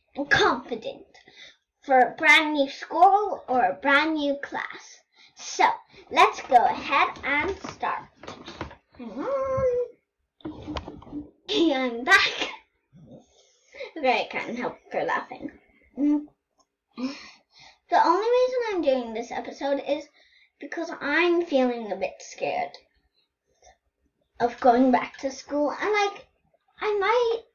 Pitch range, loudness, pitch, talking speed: 265-405 Hz, -24 LUFS, 295 Hz, 110 wpm